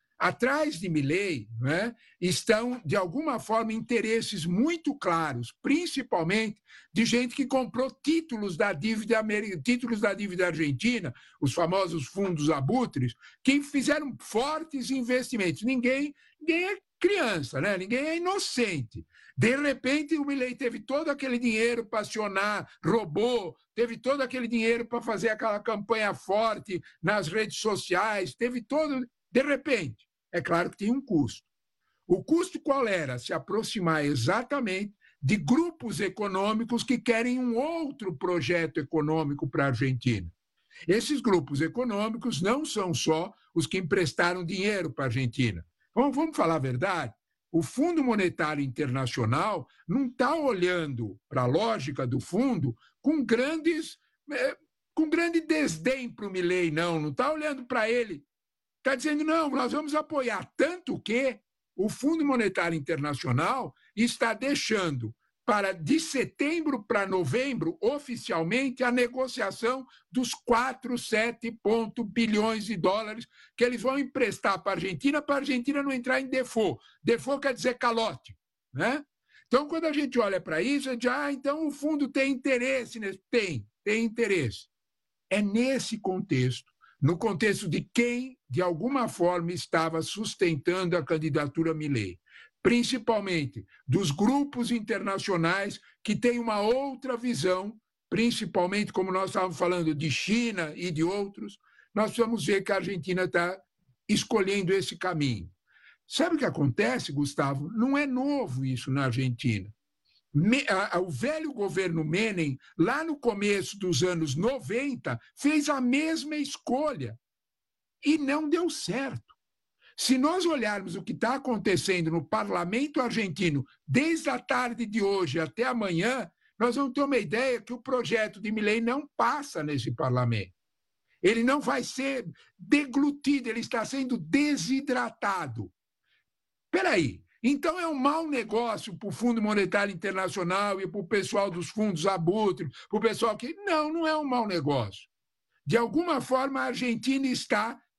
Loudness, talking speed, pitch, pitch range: -28 LUFS, 140 wpm, 225 Hz, 180-260 Hz